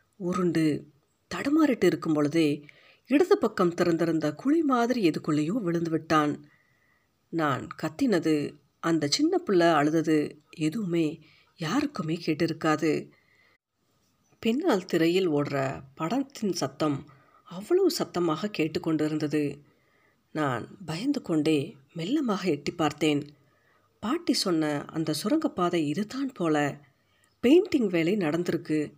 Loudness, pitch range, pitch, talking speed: -27 LUFS, 150-205 Hz, 165 Hz, 90 wpm